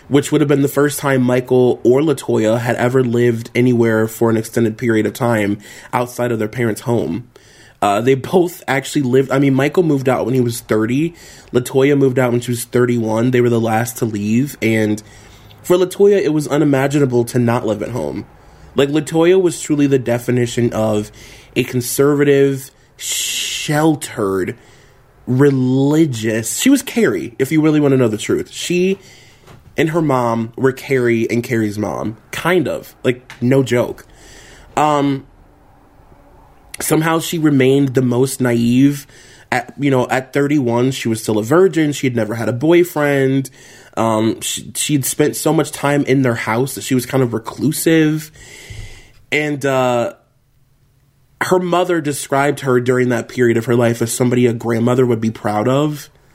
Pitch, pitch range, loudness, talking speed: 130 Hz, 115-140 Hz, -16 LUFS, 170 wpm